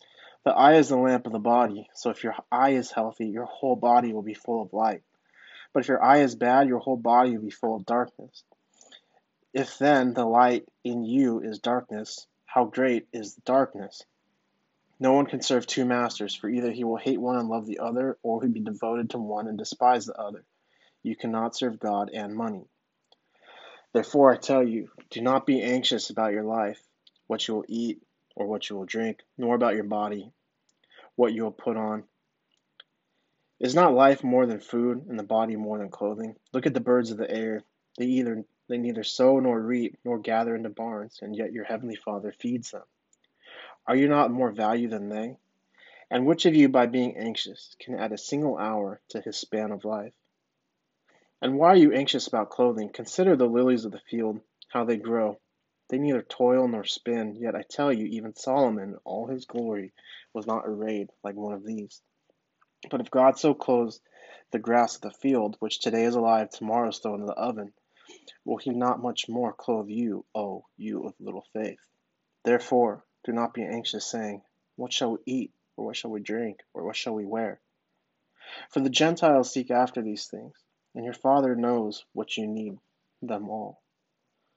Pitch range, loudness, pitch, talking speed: 110-125 Hz, -26 LUFS, 120 Hz, 195 wpm